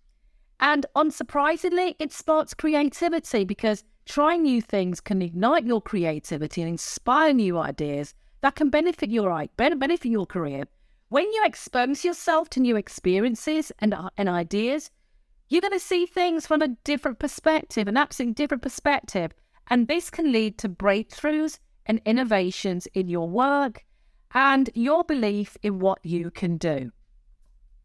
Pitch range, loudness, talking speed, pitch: 190-305 Hz, -24 LUFS, 140 wpm, 250 Hz